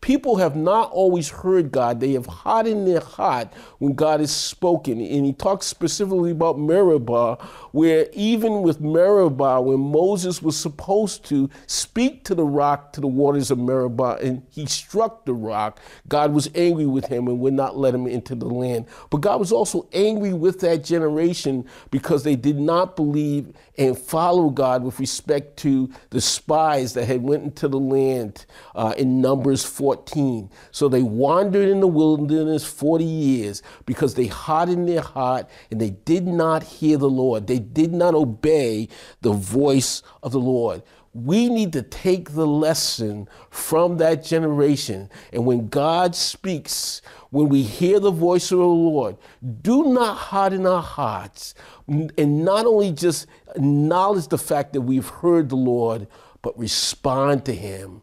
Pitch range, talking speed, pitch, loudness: 130-175 Hz, 165 wpm, 145 Hz, -20 LUFS